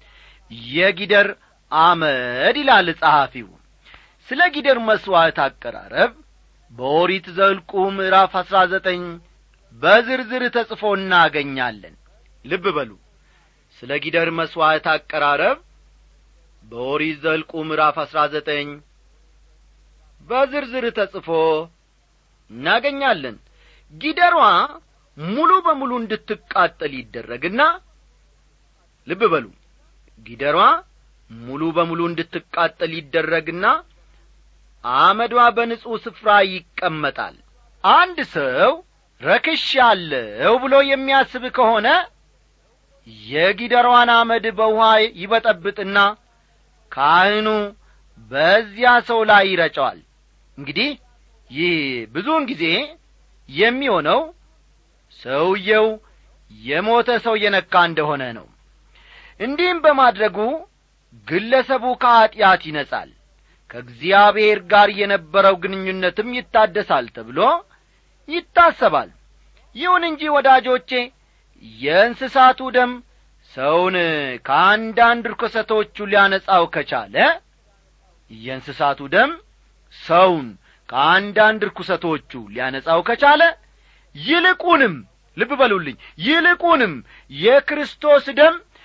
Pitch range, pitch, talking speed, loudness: 165-255 Hz, 205 Hz, 75 wpm, -17 LUFS